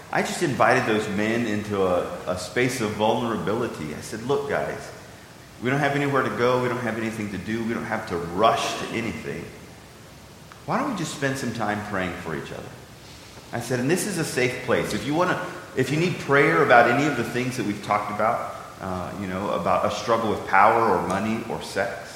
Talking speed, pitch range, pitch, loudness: 220 wpm, 105-140 Hz, 115 Hz, -24 LUFS